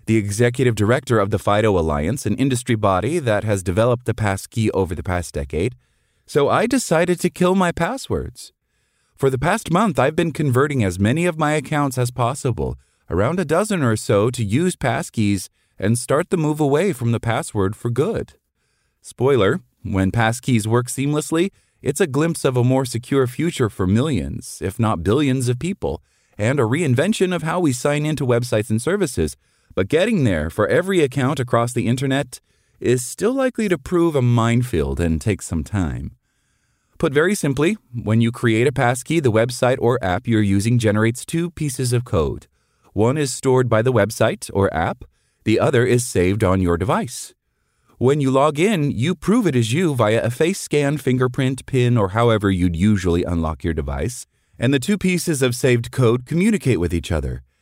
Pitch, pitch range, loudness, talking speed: 120 Hz, 105-145 Hz, -19 LUFS, 185 wpm